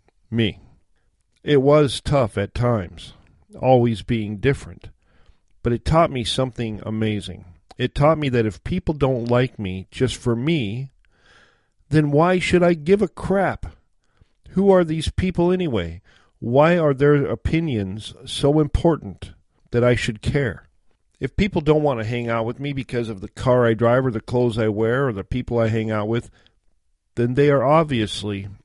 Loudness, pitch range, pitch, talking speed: -20 LUFS, 105-145 Hz, 120 Hz, 170 wpm